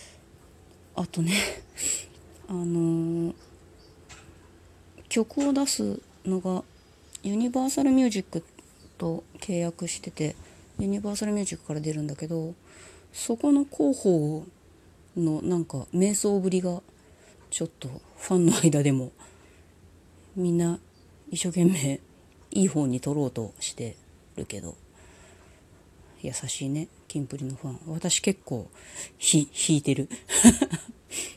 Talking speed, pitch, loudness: 220 characters per minute, 155 Hz, -27 LUFS